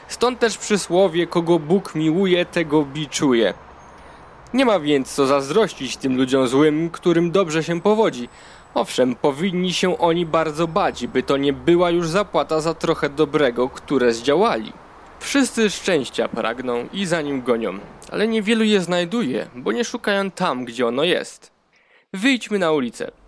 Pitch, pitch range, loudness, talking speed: 170 Hz, 145-200 Hz, -20 LUFS, 150 wpm